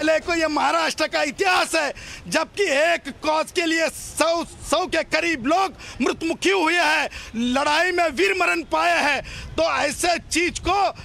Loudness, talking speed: -21 LUFS, 160 wpm